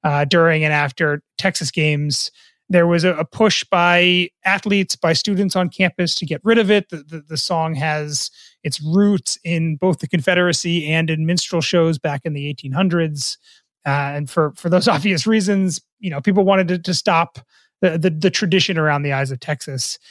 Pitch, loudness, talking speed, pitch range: 170 Hz, -18 LUFS, 190 wpm, 150-185 Hz